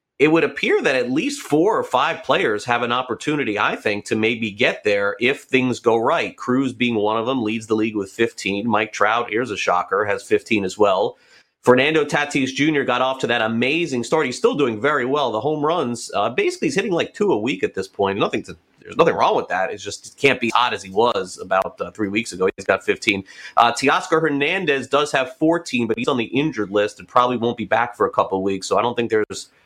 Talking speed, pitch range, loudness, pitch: 245 wpm, 110-150 Hz, -20 LUFS, 125 Hz